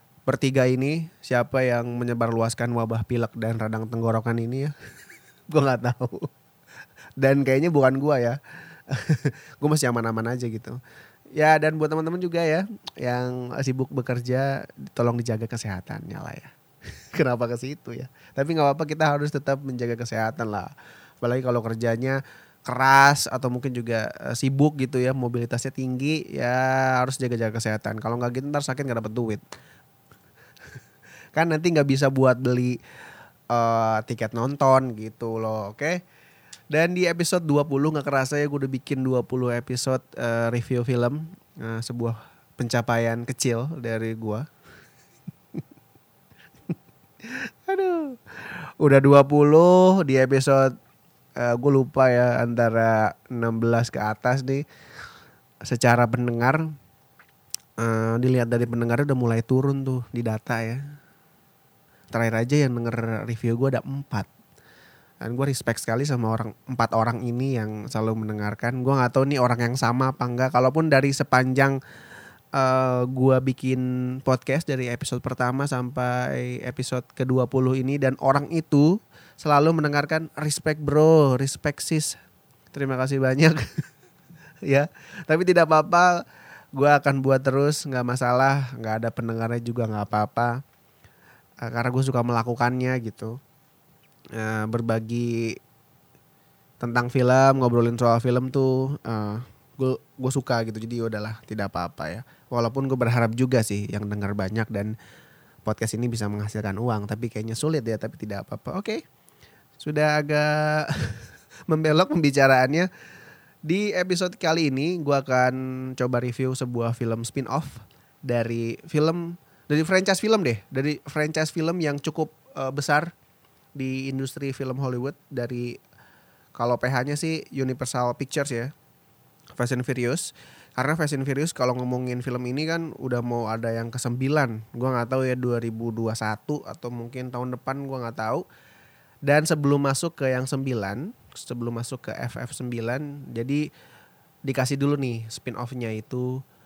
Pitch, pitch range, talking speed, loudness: 130 Hz, 120-145 Hz, 140 wpm, -24 LUFS